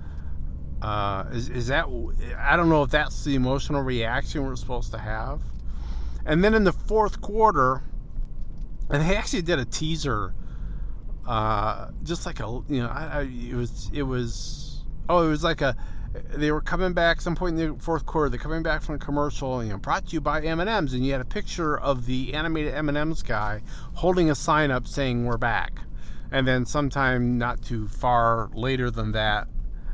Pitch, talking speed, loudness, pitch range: 135 Hz, 200 wpm, -26 LUFS, 115-155 Hz